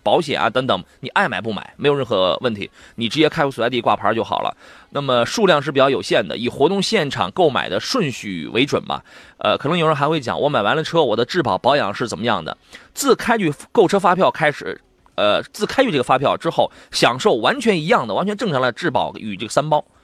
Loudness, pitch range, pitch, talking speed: -18 LUFS, 120-160 Hz, 145 Hz, 340 characters per minute